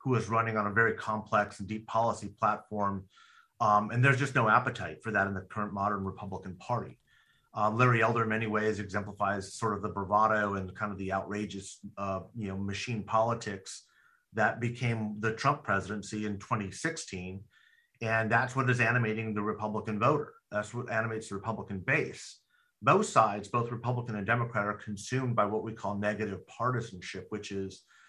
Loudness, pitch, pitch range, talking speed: -31 LUFS, 105 Hz, 100-115 Hz, 175 wpm